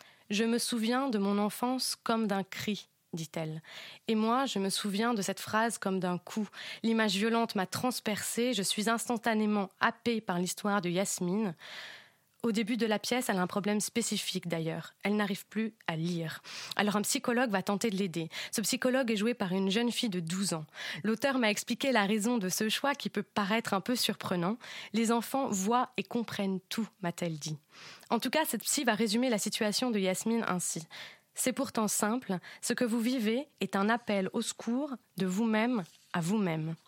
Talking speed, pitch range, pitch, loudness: 190 wpm, 195-235 Hz, 215 Hz, -32 LUFS